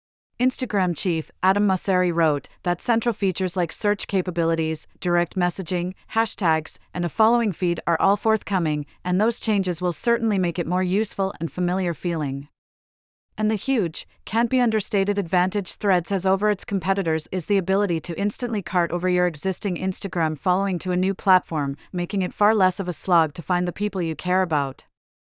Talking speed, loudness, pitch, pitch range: 175 wpm, -23 LUFS, 185 Hz, 170-200 Hz